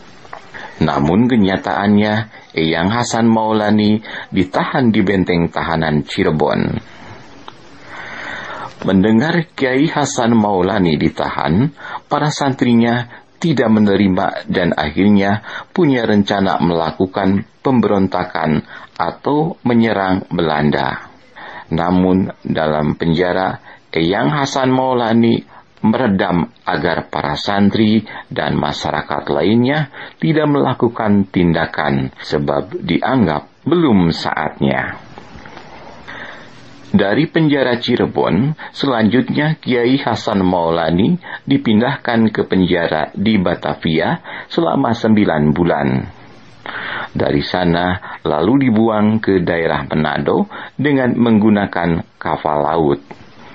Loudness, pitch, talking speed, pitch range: -16 LUFS, 100 Hz, 85 wpm, 85-115 Hz